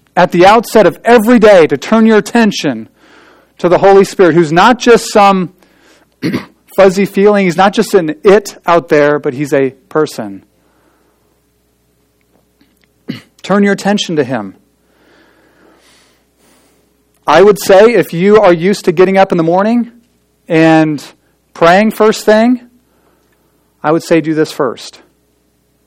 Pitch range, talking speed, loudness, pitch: 145-205 Hz, 135 wpm, -9 LUFS, 175 Hz